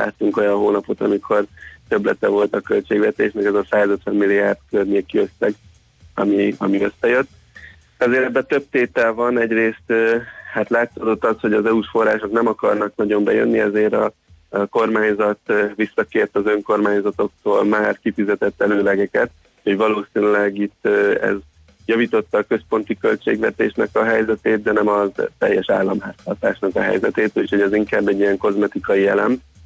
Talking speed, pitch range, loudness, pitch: 140 wpm, 100-110 Hz, -18 LUFS, 105 Hz